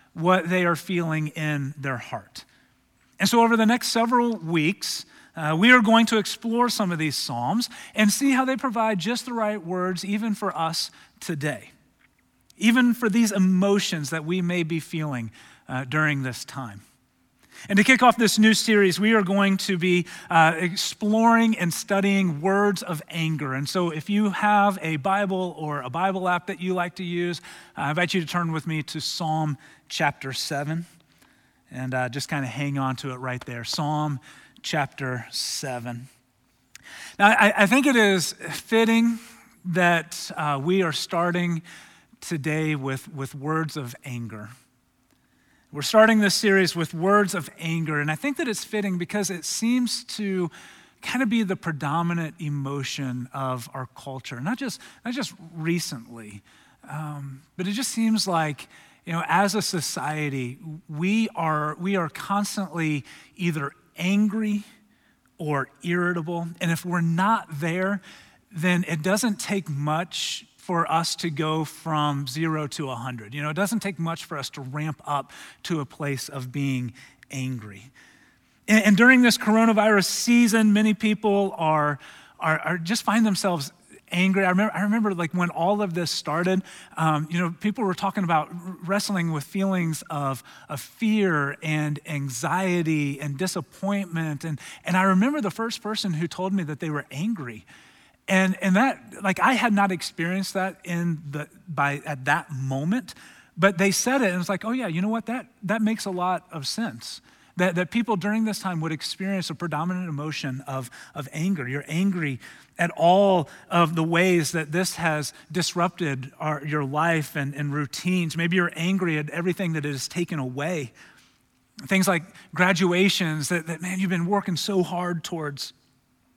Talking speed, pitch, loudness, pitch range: 170 wpm, 175 Hz, -24 LUFS, 150-200 Hz